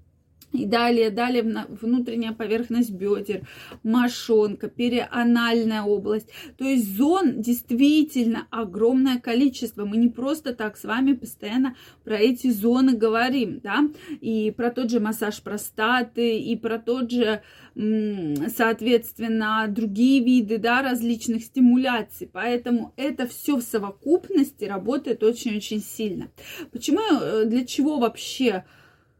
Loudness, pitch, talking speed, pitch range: -23 LUFS, 235 Hz, 115 wpm, 220-255 Hz